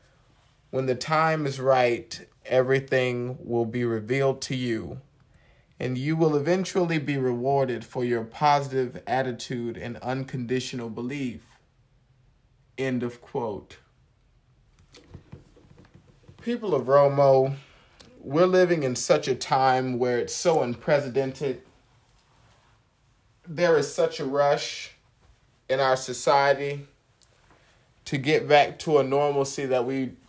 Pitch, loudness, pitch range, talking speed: 130 Hz, -25 LUFS, 125-140 Hz, 110 wpm